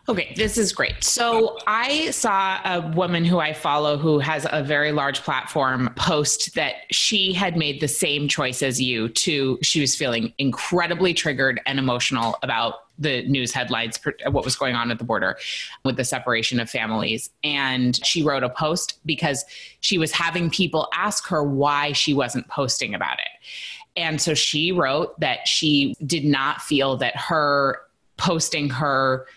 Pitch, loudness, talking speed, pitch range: 145 Hz, -21 LUFS, 170 wpm, 130-165 Hz